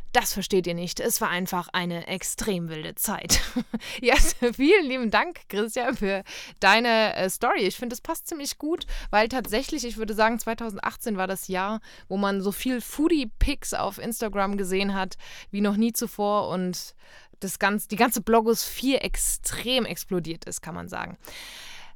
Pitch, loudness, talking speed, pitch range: 220 Hz, -25 LUFS, 160 wpm, 195-245 Hz